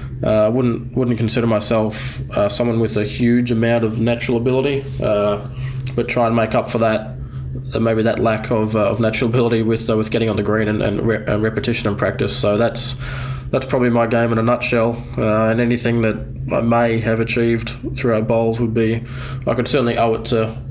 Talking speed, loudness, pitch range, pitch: 210 wpm, -18 LUFS, 110-125 Hz, 115 Hz